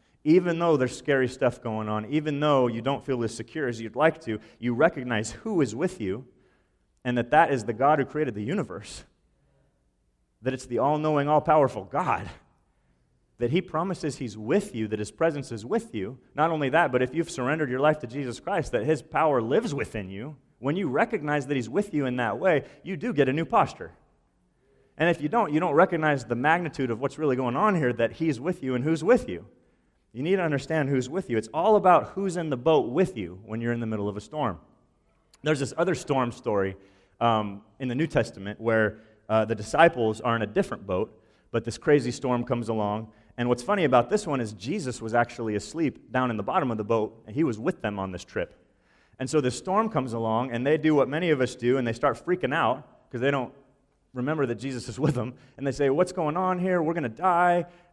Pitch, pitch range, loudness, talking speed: 130 Hz, 115-155 Hz, -26 LUFS, 235 wpm